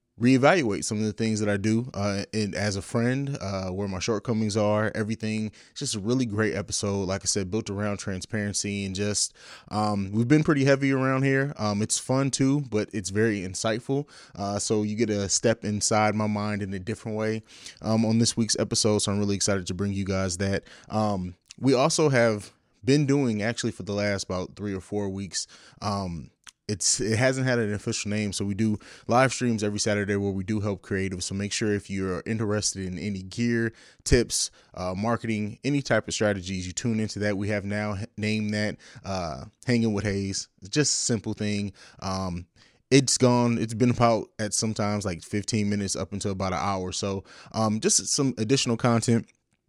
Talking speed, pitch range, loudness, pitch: 200 wpm, 100-115 Hz, -26 LUFS, 105 Hz